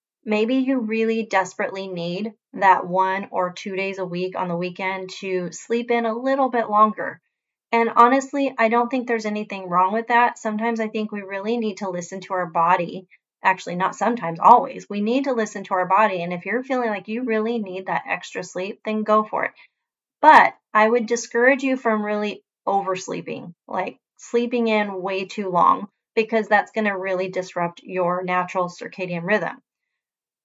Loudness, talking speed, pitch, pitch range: -21 LUFS, 185 wpm, 210 Hz, 185-230 Hz